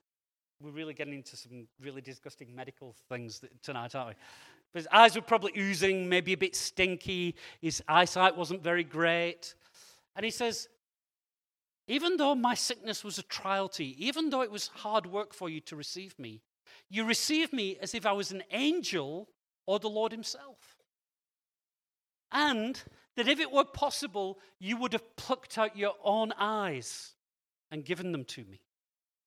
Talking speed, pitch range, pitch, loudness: 170 wpm, 155-225 Hz, 195 Hz, -31 LUFS